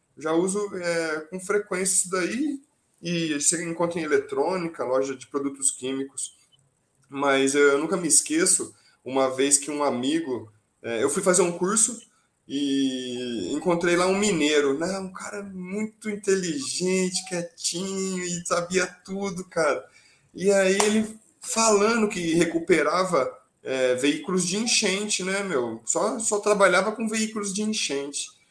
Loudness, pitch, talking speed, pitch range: -24 LUFS, 180 Hz, 140 wpm, 145-205 Hz